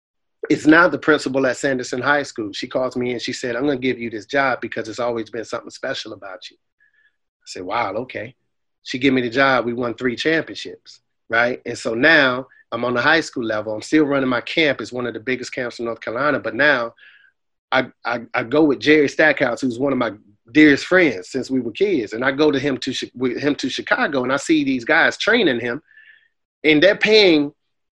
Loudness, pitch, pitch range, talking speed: -18 LUFS, 135 Hz, 125-155 Hz, 225 wpm